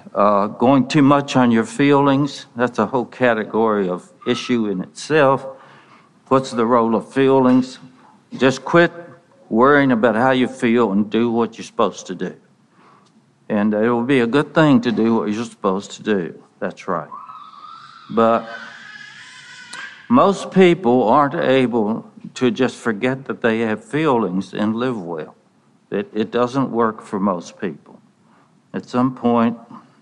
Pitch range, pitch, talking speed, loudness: 115-140 Hz, 125 Hz, 150 wpm, -18 LUFS